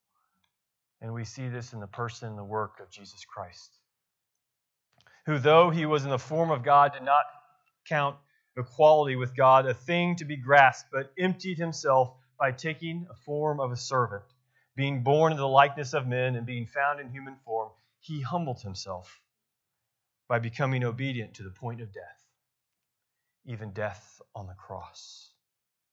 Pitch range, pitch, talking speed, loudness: 115-145 Hz, 130 Hz, 165 wpm, -27 LUFS